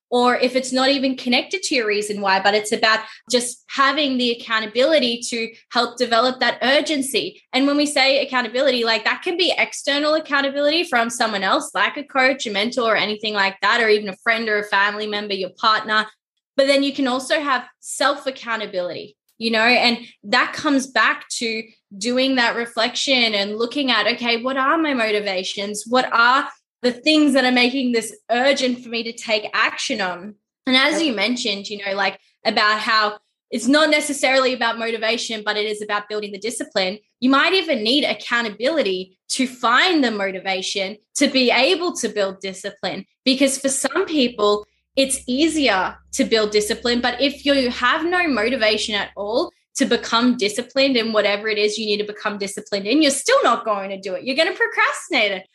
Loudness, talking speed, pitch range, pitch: -19 LUFS, 190 wpm, 210-270 Hz, 235 Hz